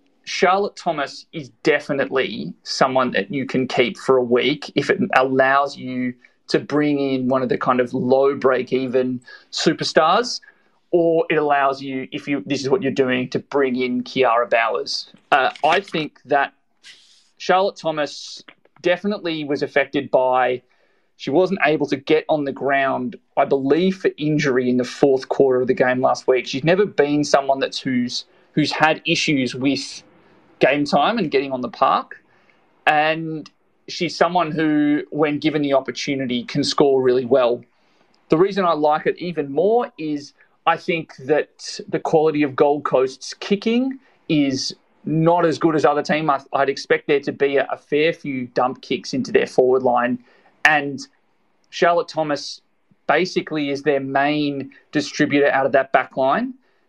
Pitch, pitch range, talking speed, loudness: 145 Hz, 130-155 Hz, 165 wpm, -19 LUFS